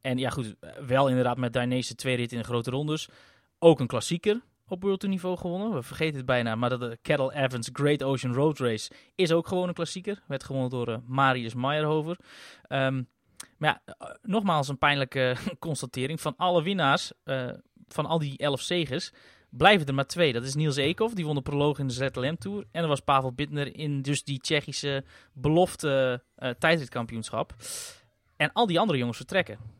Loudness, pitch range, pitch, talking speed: -27 LUFS, 130-165 Hz, 140 Hz, 185 wpm